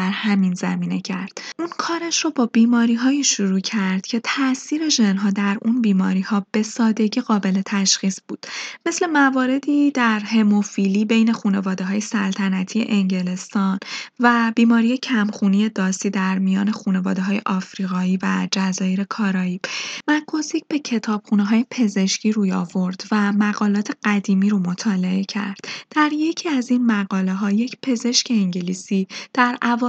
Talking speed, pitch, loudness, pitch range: 135 wpm, 210 Hz, -20 LUFS, 195-240 Hz